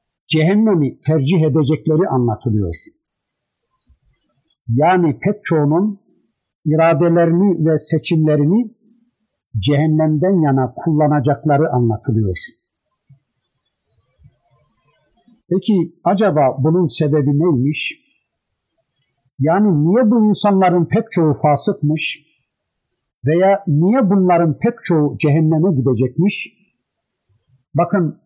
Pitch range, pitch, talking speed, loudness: 140-185 Hz, 155 Hz, 70 wpm, -15 LUFS